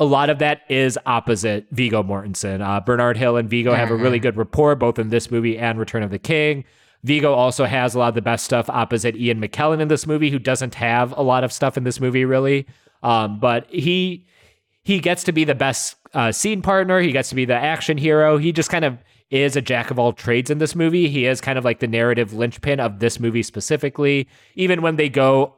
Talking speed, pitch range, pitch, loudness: 235 wpm, 115-150 Hz, 130 Hz, -19 LUFS